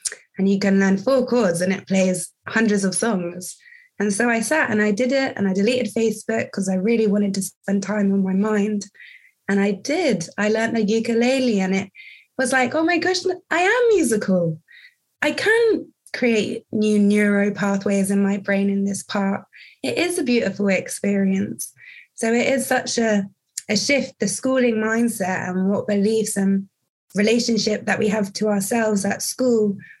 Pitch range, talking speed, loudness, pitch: 195-255 Hz, 180 wpm, -20 LUFS, 215 Hz